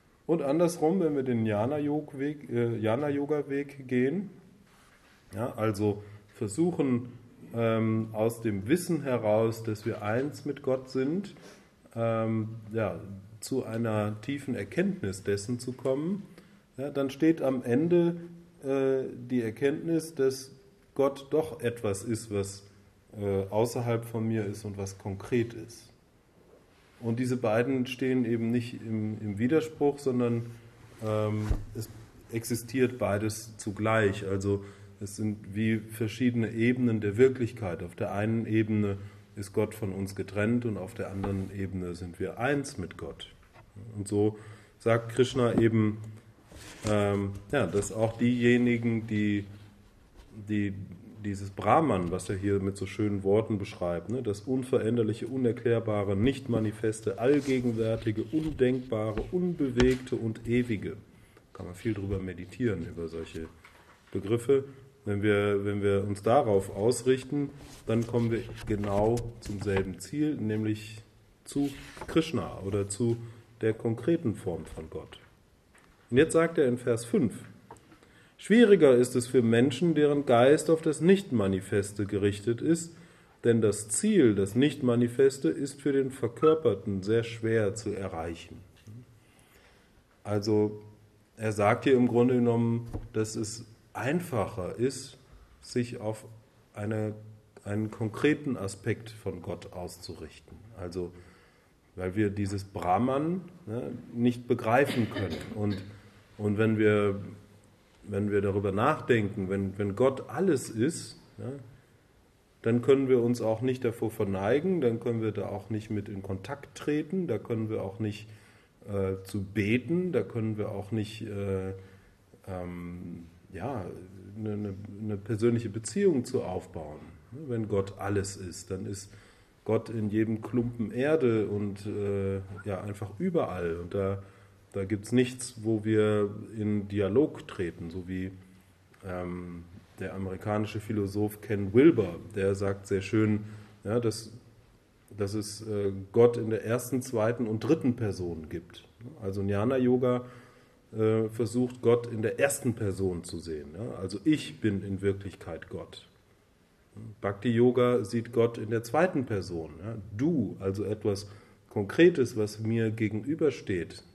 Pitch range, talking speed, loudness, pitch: 100-125 Hz, 135 wpm, -29 LUFS, 110 Hz